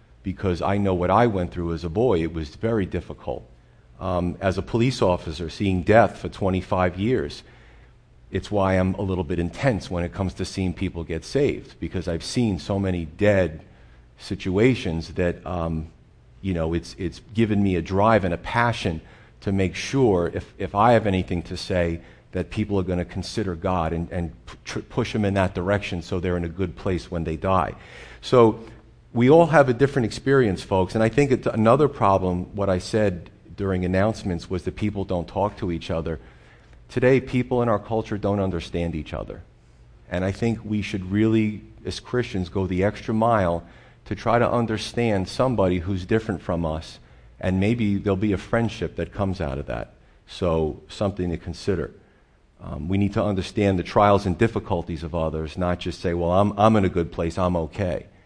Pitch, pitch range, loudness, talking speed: 95 Hz, 85-105 Hz, -23 LUFS, 200 wpm